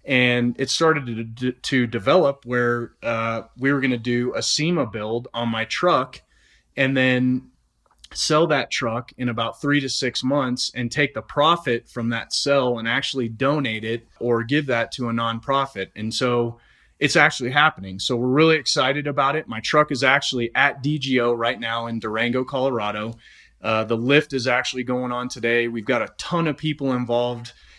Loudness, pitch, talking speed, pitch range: -21 LUFS, 125 Hz, 185 wpm, 115-135 Hz